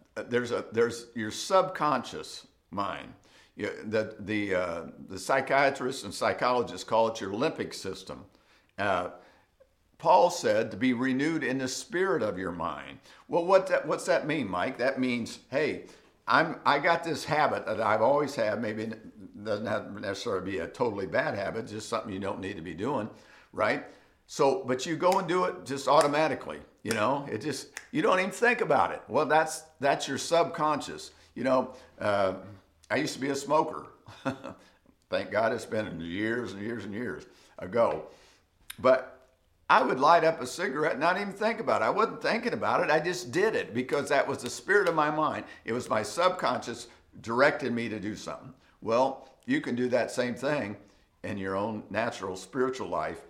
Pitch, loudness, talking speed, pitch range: 125 Hz, -29 LUFS, 185 wpm, 110-150 Hz